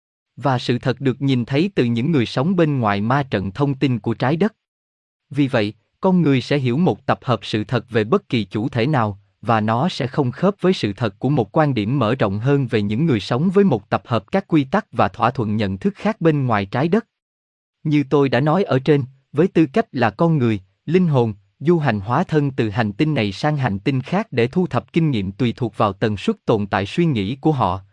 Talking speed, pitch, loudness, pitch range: 245 wpm, 125 Hz, -19 LUFS, 110-155 Hz